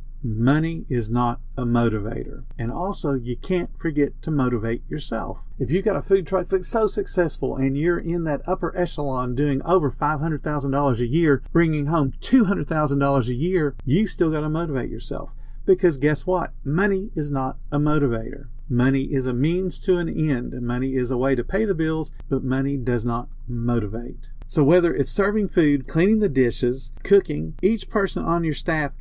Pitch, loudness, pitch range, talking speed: 145 Hz, -23 LUFS, 125-175 Hz, 180 wpm